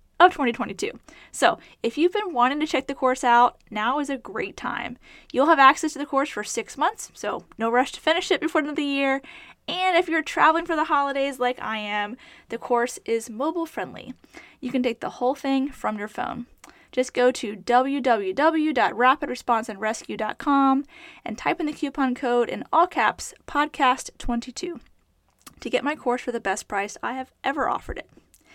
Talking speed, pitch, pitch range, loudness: 185 wpm, 270 Hz, 240-310 Hz, -24 LUFS